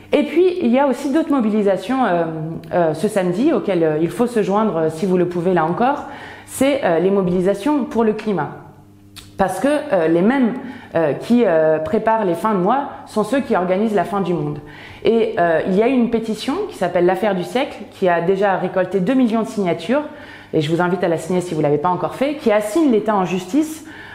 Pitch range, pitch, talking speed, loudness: 175-255 Hz, 200 Hz, 230 wpm, -18 LUFS